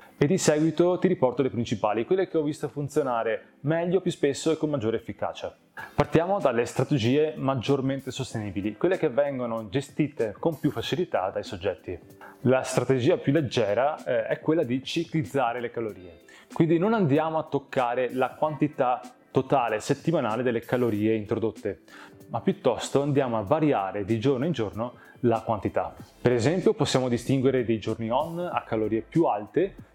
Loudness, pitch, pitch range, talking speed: -26 LUFS, 135 Hz, 115-155 Hz, 155 wpm